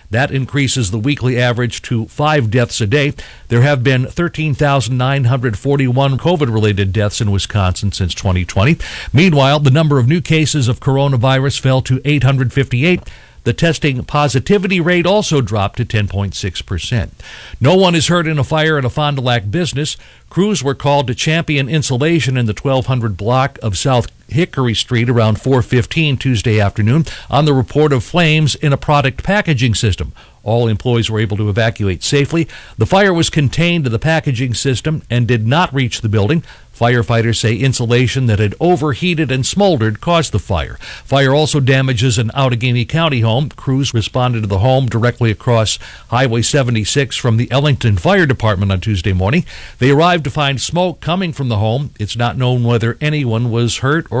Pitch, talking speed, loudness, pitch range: 130 Hz, 170 wpm, -14 LUFS, 115-150 Hz